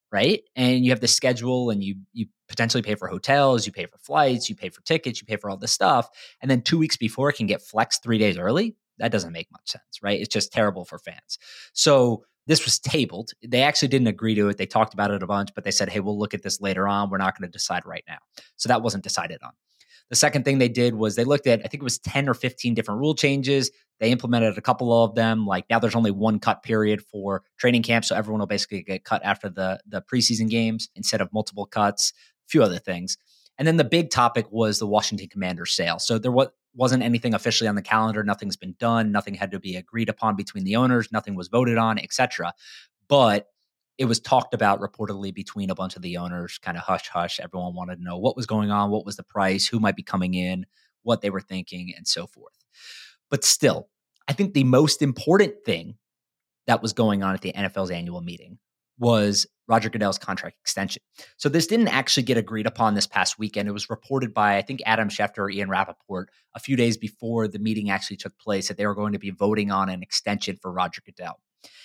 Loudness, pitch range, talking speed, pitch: -23 LUFS, 100-120 Hz, 235 wpm, 110 Hz